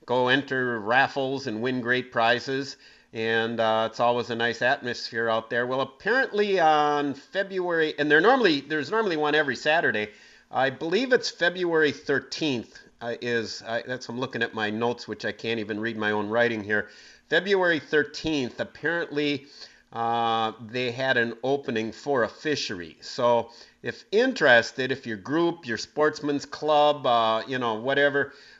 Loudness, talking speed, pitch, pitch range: -25 LUFS, 155 wpm, 125 Hz, 115-145 Hz